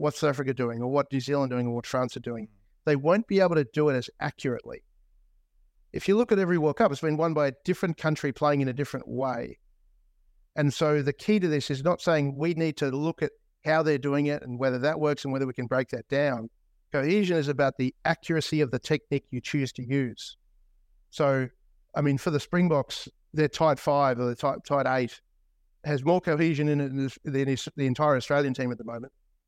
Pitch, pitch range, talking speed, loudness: 140 Hz, 130-155 Hz, 230 wpm, -27 LUFS